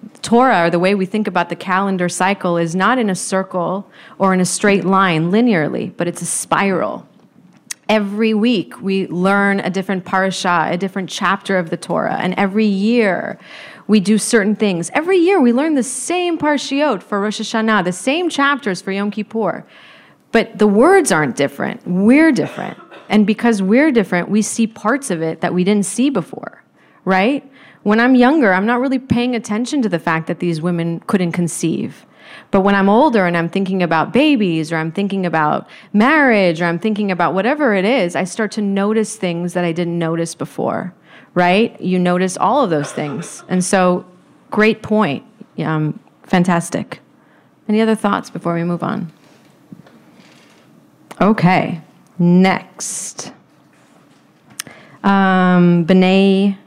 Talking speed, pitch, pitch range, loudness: 165 wpm, 195 Hz, 180-225 Hz, -16 LUFS